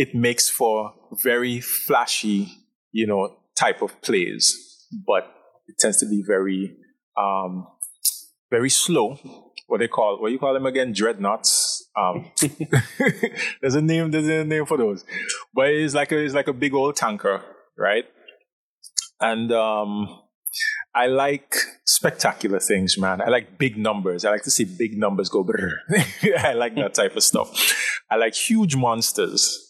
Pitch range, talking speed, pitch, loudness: 105-155 Hz, 155 wpm, 130 Hz, -21 LUFS